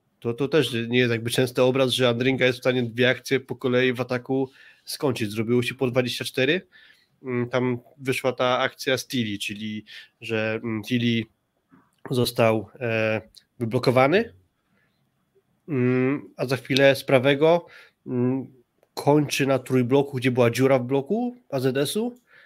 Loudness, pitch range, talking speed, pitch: -23 LUFS, 120-135 Hz, 130 wpm, 130 Hz